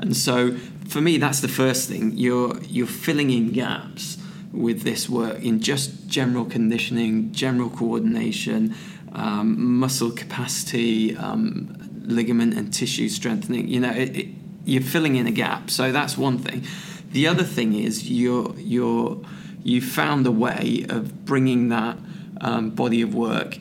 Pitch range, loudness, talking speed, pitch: 120-185 Hz, -23 LUFS, 150 wpm, 135 Hz